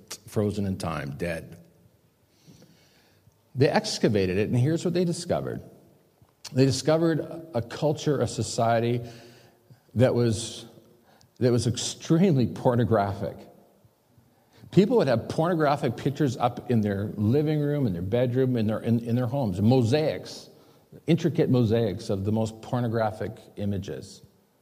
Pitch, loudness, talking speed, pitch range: 120 Hz, -26 LUFS, 125 wpm, 110-145 Hz